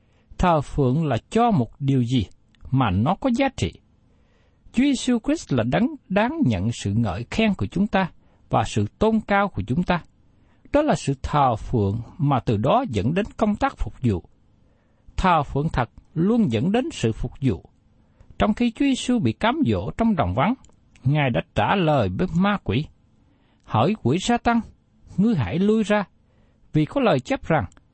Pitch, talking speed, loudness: 160 Hz, 185 wpm, -22 LUFS